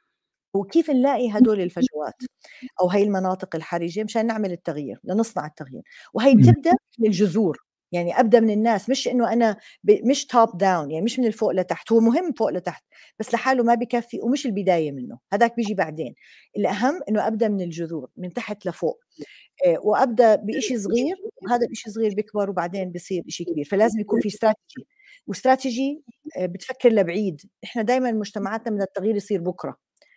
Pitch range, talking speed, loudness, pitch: 185-240 Hz, 155 wpm, -22 LUFS, 215 Hz